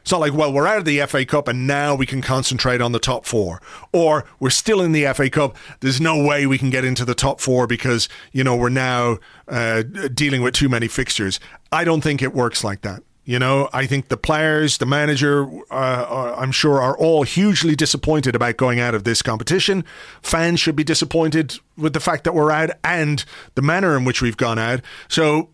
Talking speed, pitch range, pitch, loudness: 225 wpm, 125-155 Hz, 140 Hz, -18 LUFS